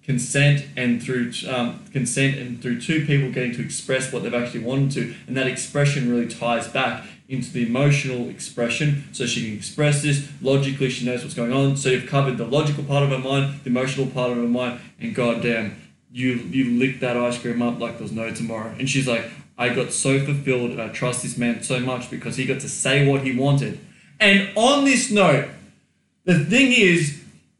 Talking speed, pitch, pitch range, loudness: 205 wpm, 130 Hz, 120-140 Hz, -21 LUFS